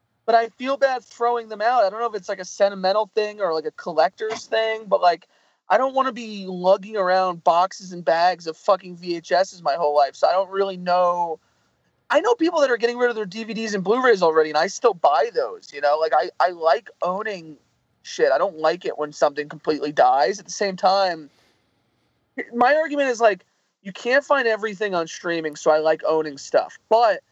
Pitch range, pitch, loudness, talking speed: 170-230 Hz, 195 Hz, -21 LUFS, 215 wpm